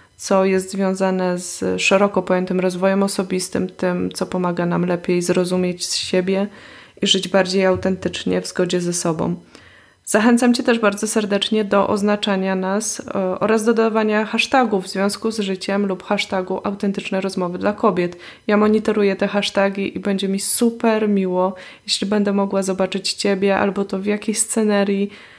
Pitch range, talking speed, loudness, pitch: 185-210 Hz, 155 wpm, -19 LUFS, 195 Hz